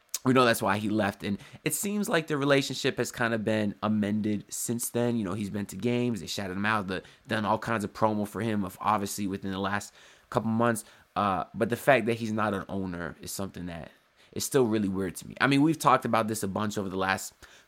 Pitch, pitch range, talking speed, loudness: 105 Hz, 100-120 Hz, 245 wpm, -28 LUFS